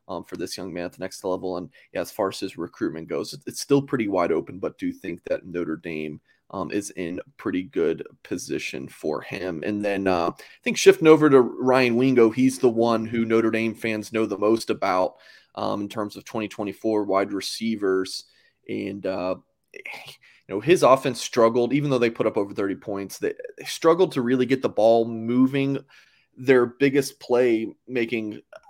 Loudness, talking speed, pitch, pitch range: -23 LUFS, 195 wpm, 115 Hz, 100-130 Hz